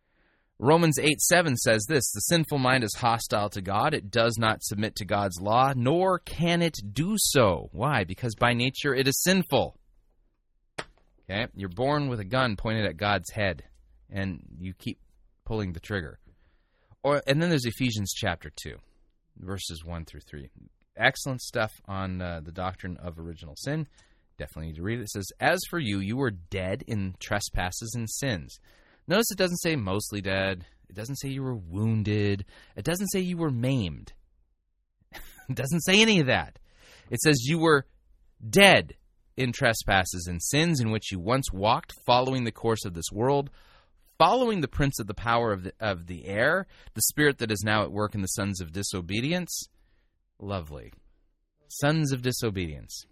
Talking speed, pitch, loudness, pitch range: 175 wpm, 110 Hz, -26 LUFS, 95-135 Hz